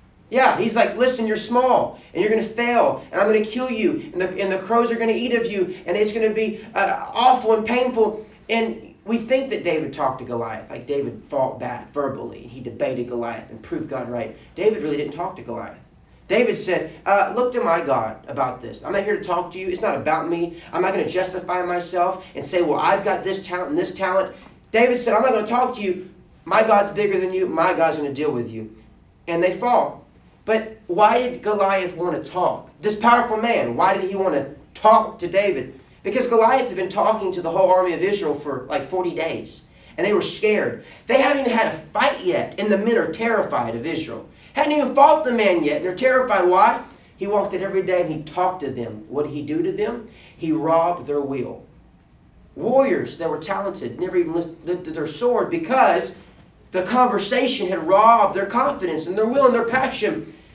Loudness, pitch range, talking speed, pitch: -21 LUFS, 165-225 Hz, 225 wpm, 190 Hz